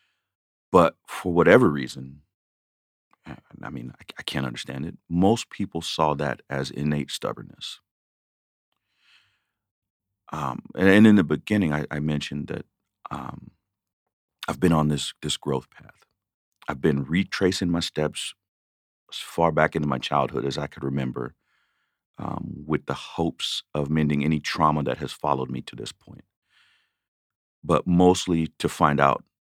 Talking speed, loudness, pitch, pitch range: 145 wpm, -24 LUFS, 75 Hz, 70-85 Hz